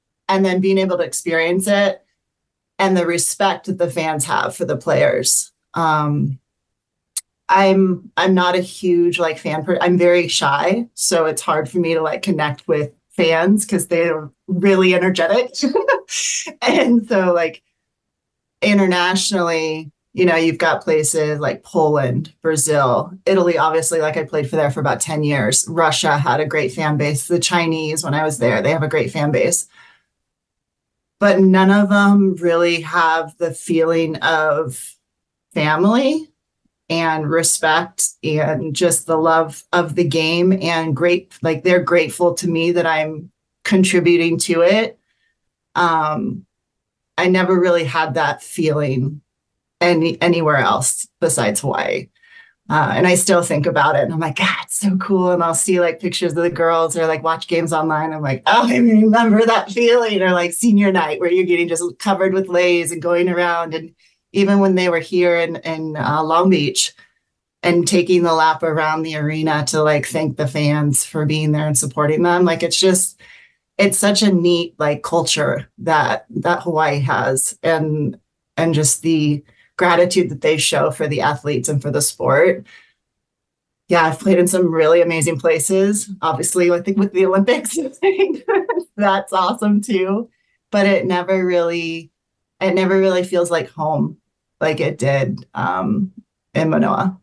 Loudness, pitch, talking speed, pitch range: -16 LUFS, 170 Hz, 165 wpm, 155-190 Hz